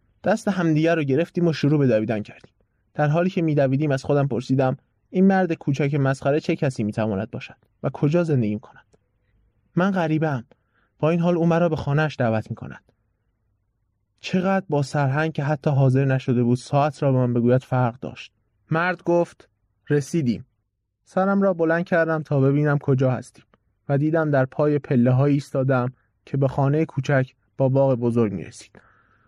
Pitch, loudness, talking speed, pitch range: 135 Hz, -22 LUFS, 160 wpm, 120-155 Hz